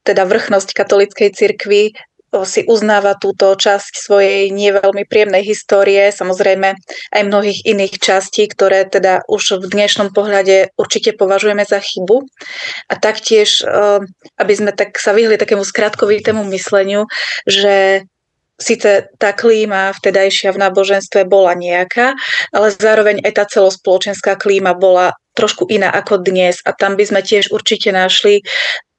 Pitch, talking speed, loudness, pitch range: 200 Hz, 130 wpm, -12 LUFS, 195-215 Hz